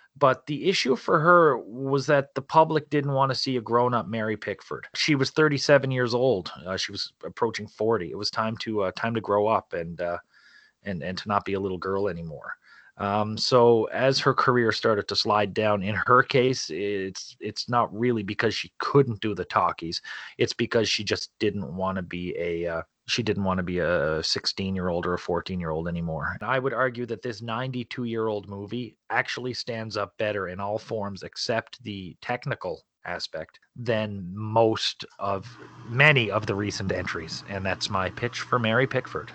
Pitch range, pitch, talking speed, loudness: 100-125 Hz, 110 Hz, 200 wpm, -26 LUFS